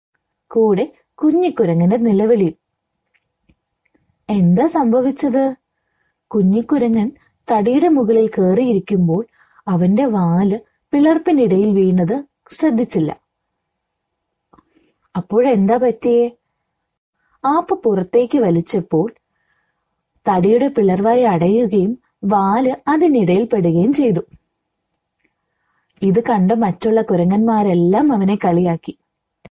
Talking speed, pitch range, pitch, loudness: 65 wpm, 180-245 Hz, 215 Hz, -16 LUFS